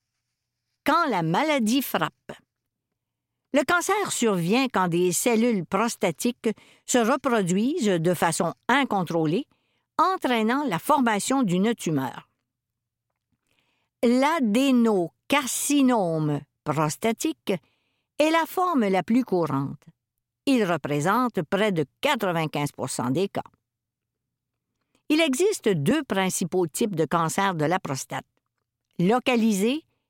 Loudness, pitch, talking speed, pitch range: -24 LUFS, 205 Hz, 95 wpm, 165-255 Hz